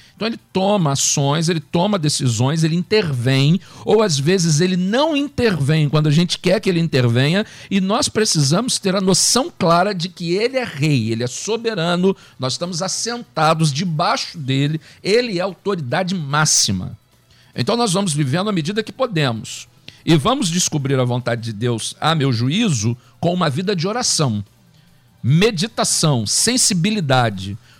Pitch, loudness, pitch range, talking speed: 165 Hz, -18 LUFS, 135-195 Hz, 155 wpm